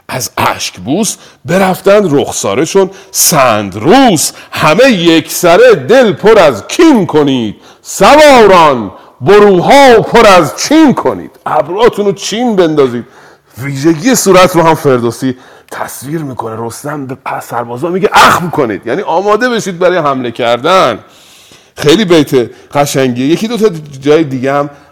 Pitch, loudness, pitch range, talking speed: 165 Hz, -8 LUFS, 135-200 Hz, 130 wpm